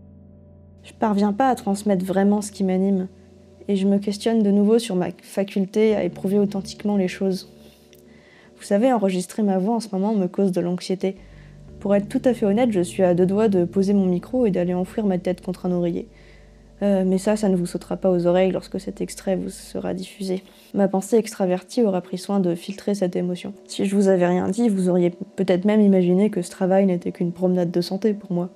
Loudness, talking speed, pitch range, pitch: -22 LUFS, 220 wpm, 180-200 Hz, 190 Hz